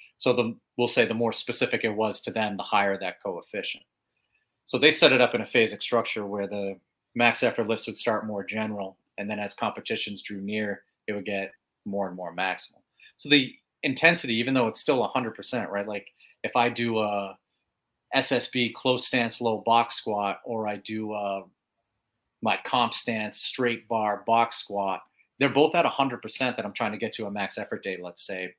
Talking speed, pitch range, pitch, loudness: 195 wpm, 100-120 Hz, 110 Hz, -26 LUFS